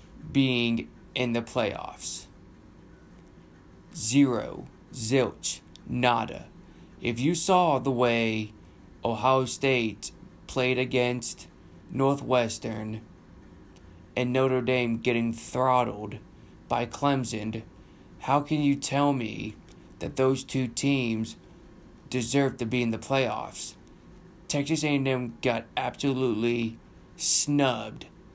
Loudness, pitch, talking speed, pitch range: -27 LUFS, 125 Hz, 95 wpm, 115-135 Hz